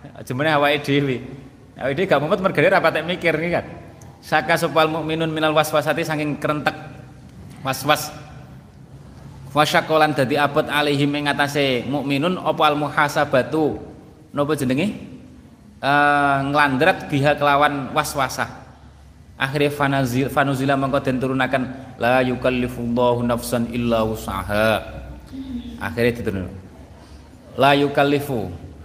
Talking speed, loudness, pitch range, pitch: 115 wpm, -20 LUFS, 125-150 Hz, 140 Hz